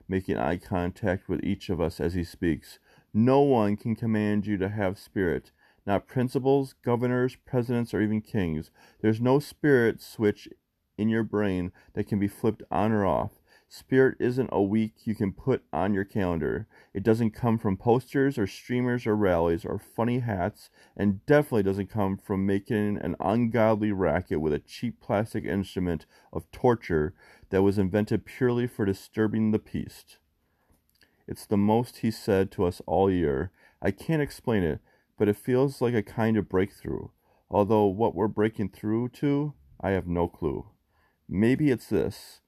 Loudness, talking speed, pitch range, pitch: -27 LUFS, 170 wpm, 95-115 Hz, 105 Hz